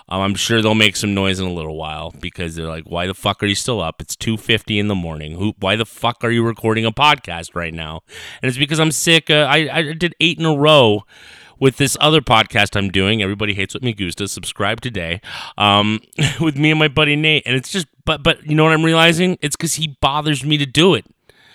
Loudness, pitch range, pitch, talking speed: -16 LUFS, 95-150 Hz, 115 Hz, 240 wpm